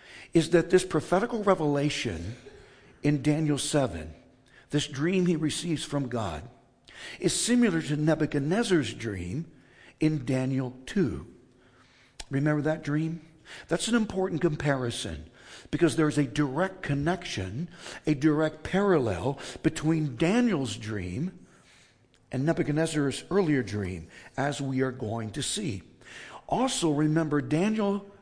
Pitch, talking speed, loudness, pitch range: 150 Hz, 115 wpm, -28 LUFS, 130-170 Hz